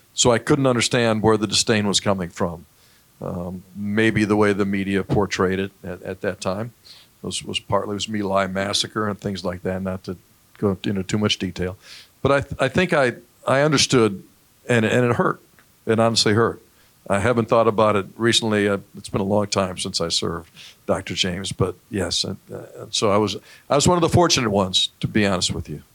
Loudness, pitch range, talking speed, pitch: -21 LUFS, 95-110 Hz, 215 wpm, 100 Hz